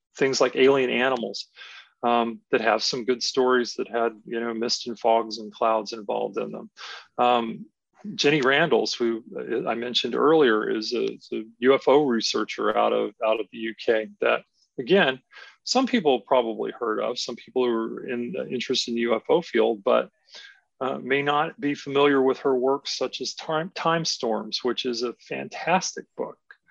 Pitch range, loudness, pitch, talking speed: 115-135 Hz, -24 LUFS, 120 Hz, 175 wpm